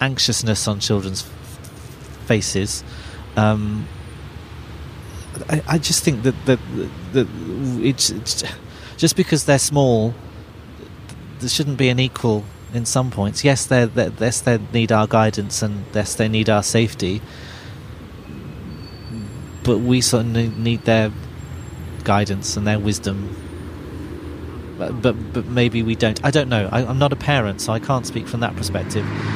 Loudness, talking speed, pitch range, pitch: -19 LUFS, 145 wpm, 100-120 Hz, 110 Hz